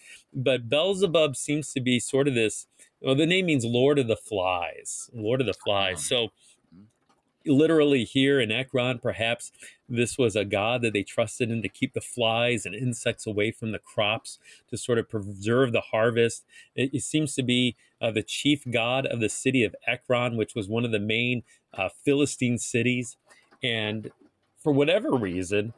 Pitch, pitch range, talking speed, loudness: 120 Hz, 110-135 Hz, 180 wpm, -26 LUFS